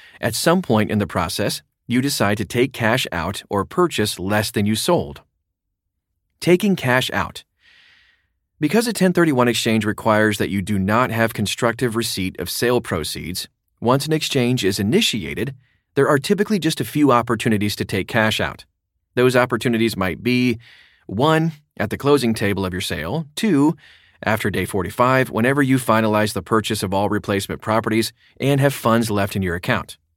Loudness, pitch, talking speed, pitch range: -19 LUFS, 110 Hz, 165 wpm, 100-130 Hz